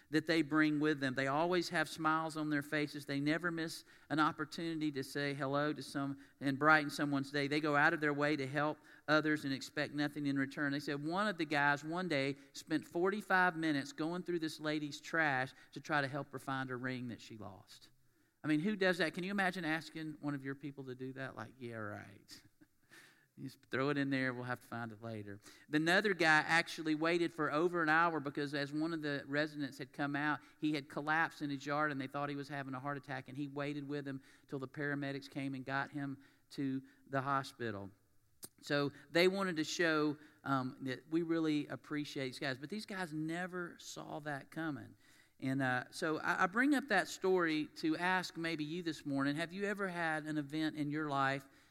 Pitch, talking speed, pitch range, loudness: 145 Hz, 215 wpm, 135-160 Hz, -37 LUFS